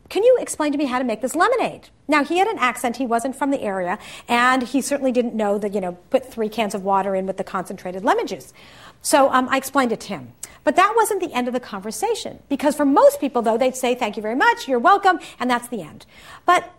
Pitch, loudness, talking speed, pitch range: 255 Hz, -20 LUFS, 255 wpm, 220-300 Hz